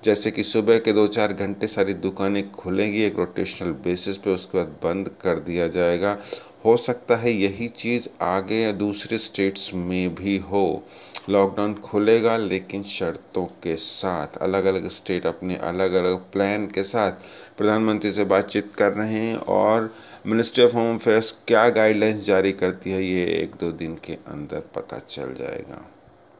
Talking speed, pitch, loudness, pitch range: 165 wpm, 100 Hz, -23 LUFS, 95-110 Hz